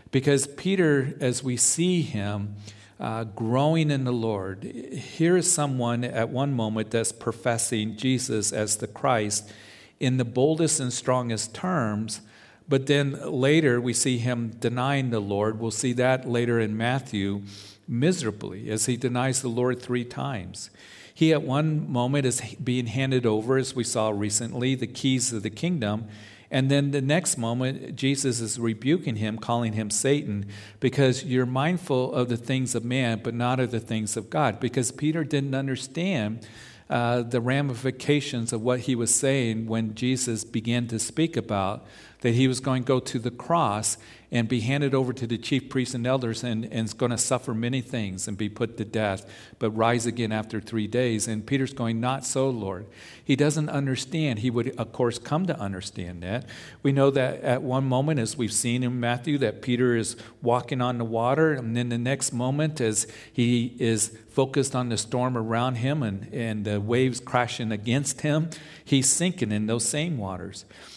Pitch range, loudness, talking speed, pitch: 110-135 Hz, -26 LUFS, 180 wpm, 120 Hz